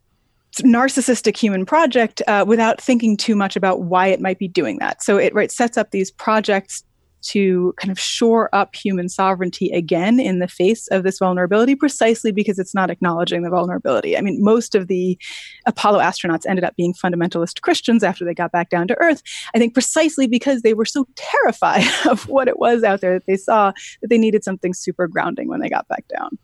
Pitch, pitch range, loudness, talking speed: 200 Hz, 185-235 Hz, -18 LUFS, 205 wpm